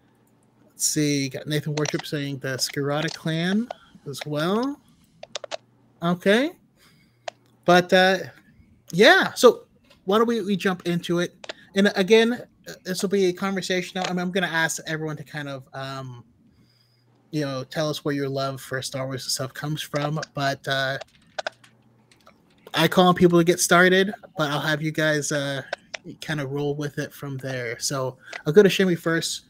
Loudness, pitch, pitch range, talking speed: -23 LUFS, 155 Hz, 140-185 Hz, 165 wpm